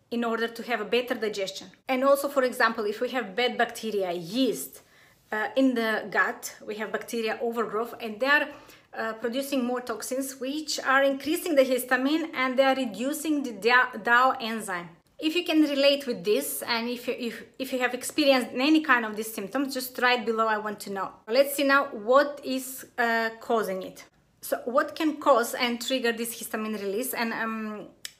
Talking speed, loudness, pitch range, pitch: 190 wpm, -26 LUFS, 225-270 Hz, 245 Hz